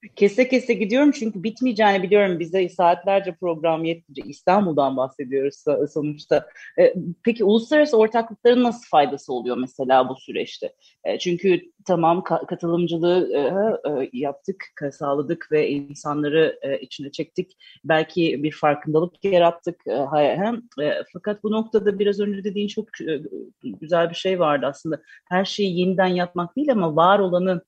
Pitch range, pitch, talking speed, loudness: 155-205 Hz, 175 Hz, 120 wpm, -21 LUFS